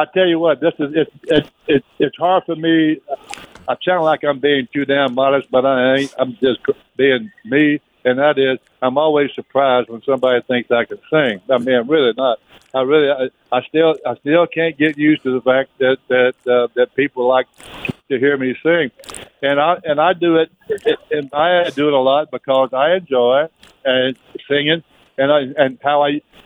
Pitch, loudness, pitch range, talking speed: 140 Hz, -16 LUFS, 130-155 Hz, 195 wpm